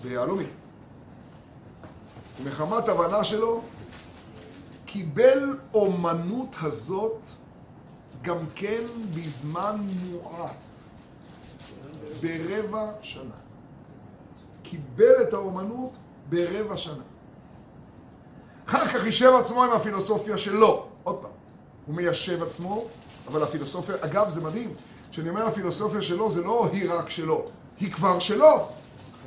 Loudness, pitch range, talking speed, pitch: -25 LUFS, 165-220 Hz, 95 wpm, 190 Hz